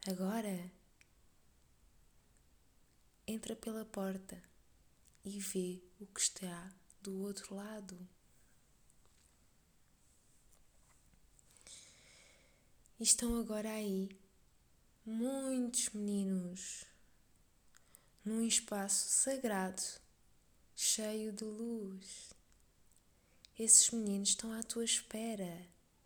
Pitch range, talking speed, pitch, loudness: 180-220 Hz, 70 wpm, 195 Hz, -36 LUFS